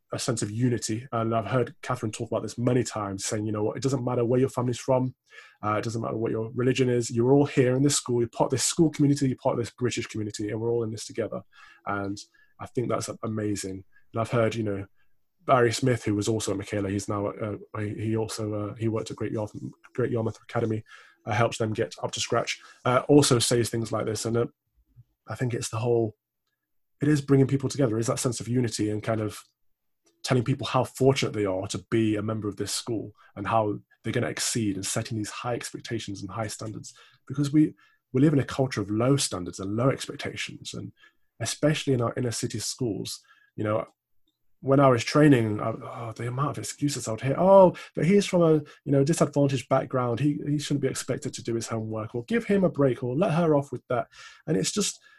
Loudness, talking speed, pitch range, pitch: -26 LUFS, 230 wpm, 110-135 Hz, 120 Hz